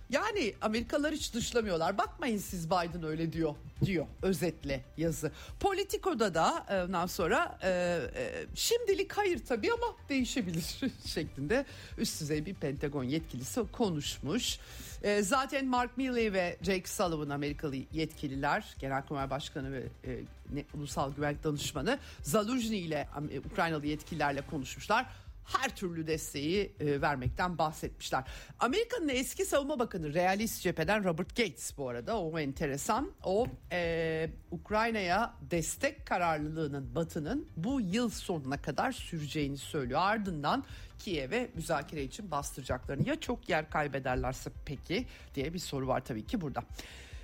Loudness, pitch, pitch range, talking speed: -34 LUFS, 170 Hz, 145-235 Hz, 120 wpm